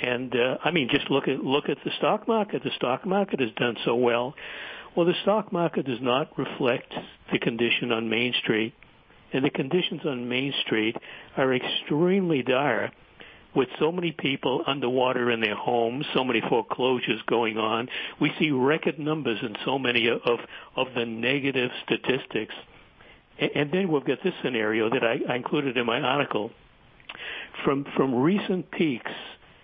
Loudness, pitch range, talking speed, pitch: -26 LUFS, 120-170 Hz, 170 wpm, 135 Hz